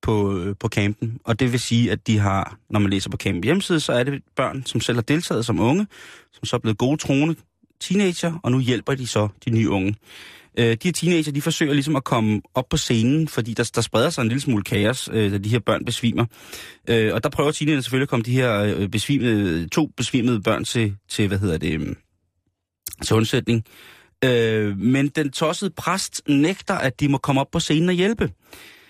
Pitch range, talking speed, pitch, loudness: 110-145 Hz, 215 wpm, 120 Hz, -21 LUFS